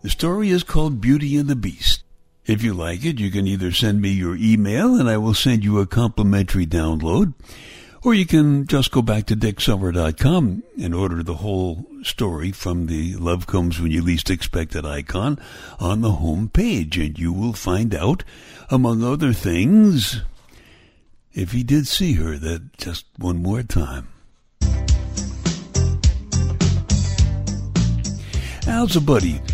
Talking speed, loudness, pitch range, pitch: 150 wpm, -20 LUFS, 85-120 Hz, 100 Hz